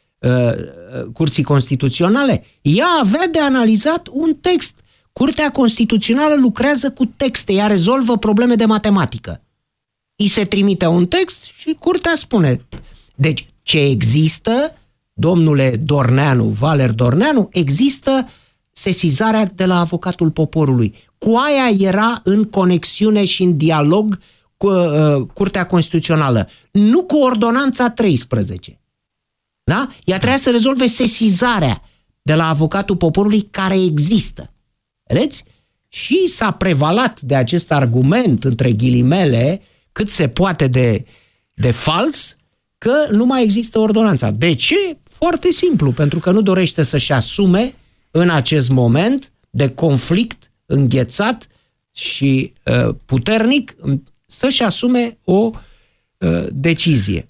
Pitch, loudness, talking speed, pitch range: 185 Hz, -15 LUFS, 115 wpm, 140-235 Hz